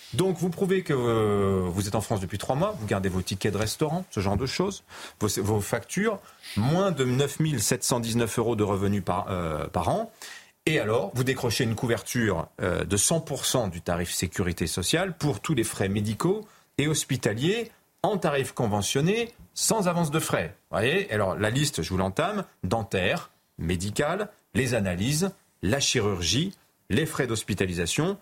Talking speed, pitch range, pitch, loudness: 165 wpm, 100-155 Hz, 120 Hz, -27 LUFS